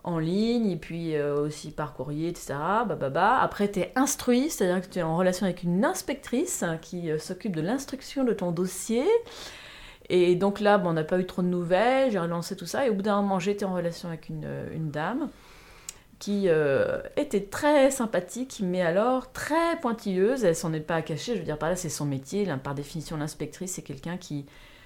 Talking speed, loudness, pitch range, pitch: 210 wpm, -27 LUFS, 160-230 Hz, 185 Hz